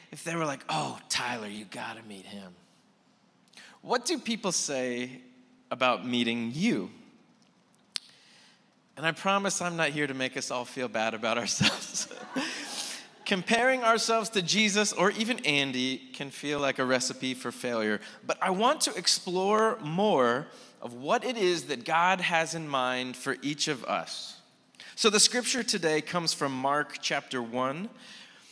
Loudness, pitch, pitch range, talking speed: -28 LUFS, 150 Hz, 125-210 Hz, 155 wpm